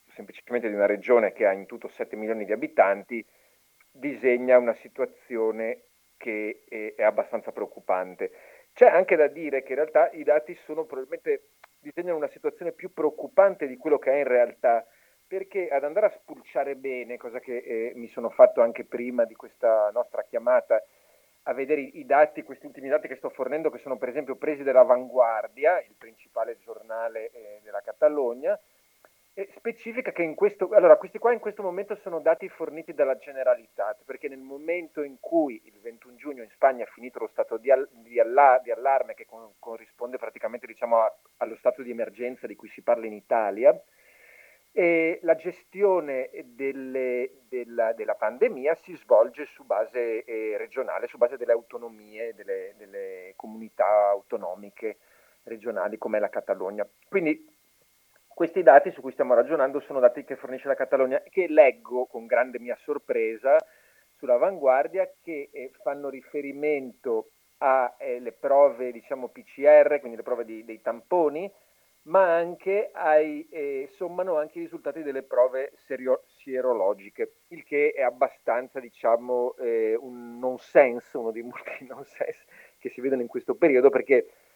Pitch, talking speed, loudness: 165 Hz, 160 wpm, -25 LUFS